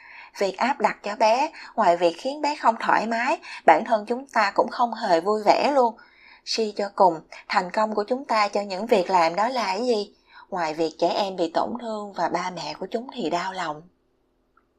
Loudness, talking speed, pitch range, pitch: -23 LUFS, 220 wpm, 180-235 Hz, 210 Hz